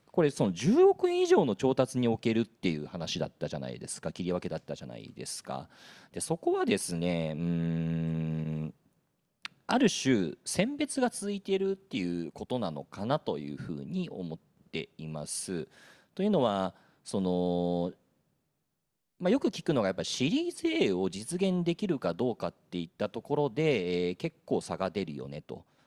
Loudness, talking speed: -31 LUFS, 320 characters per minute